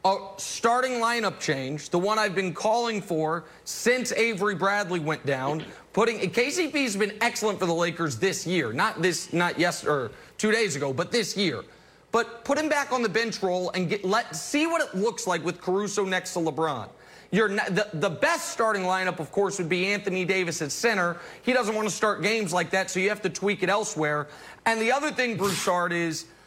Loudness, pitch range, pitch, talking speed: -26 LUFS, 175-225 Hz, 195 Hz, 210 wpm